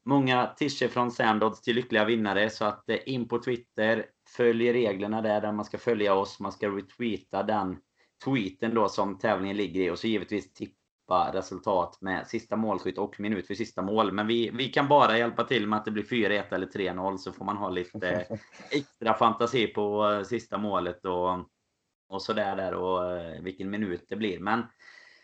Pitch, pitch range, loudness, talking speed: 105 Hz, 95-120 Hz, -28 LUFS, 185 wpm